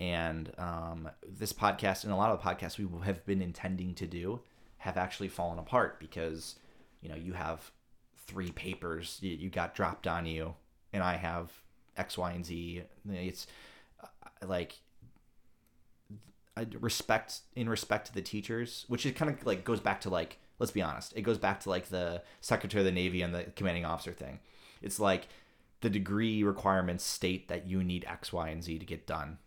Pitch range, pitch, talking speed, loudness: 85-100 Hz, 90 Hz, 185 wpm, -35 LUFS